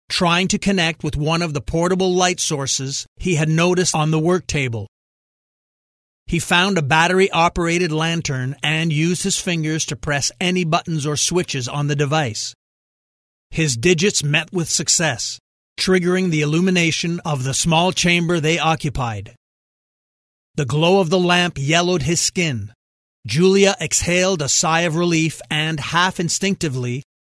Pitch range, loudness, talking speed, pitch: 145-175 Hz, -18 LUFS, 150 wpm, 160 Hz